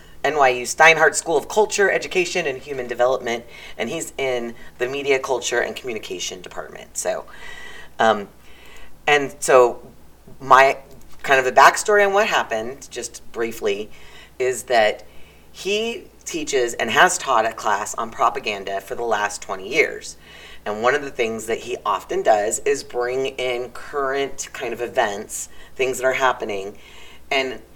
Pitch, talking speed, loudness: 135 Hz, 150 wpm, -20 LUFS